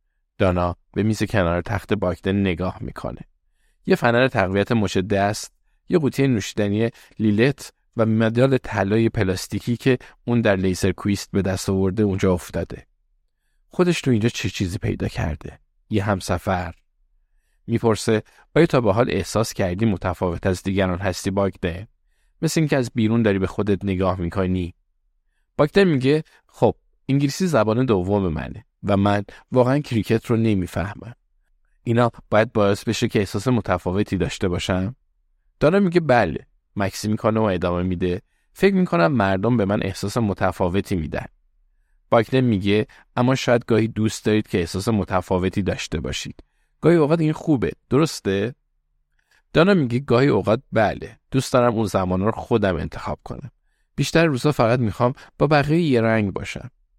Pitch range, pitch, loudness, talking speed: 95-120 Hz, 105 Hz, -21 LUFS, 145 wpm